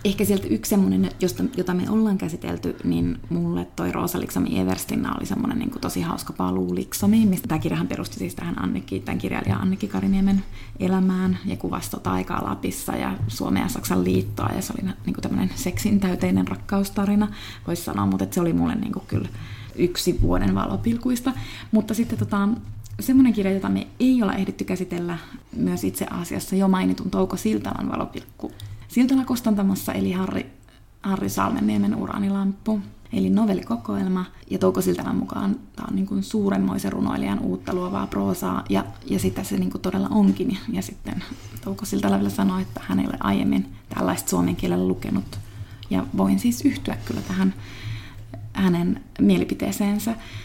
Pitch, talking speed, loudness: 105 Hz, 160 wpm, -24 LUFS